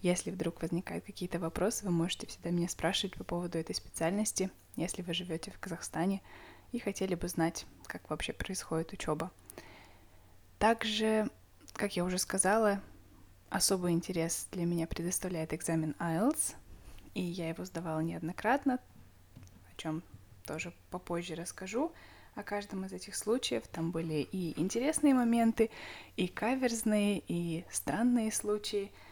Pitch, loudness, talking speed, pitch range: 175 Hz, -34 LUFS, 130 wpm, 165-205 Hz